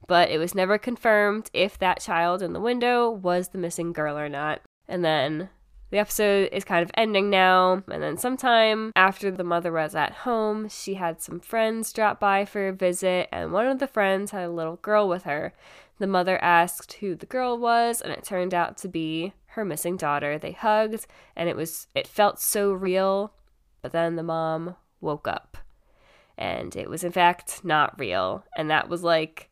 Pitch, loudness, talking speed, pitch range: 185 Hz, -25 LUFS, 195 wpm, 170-210 Hz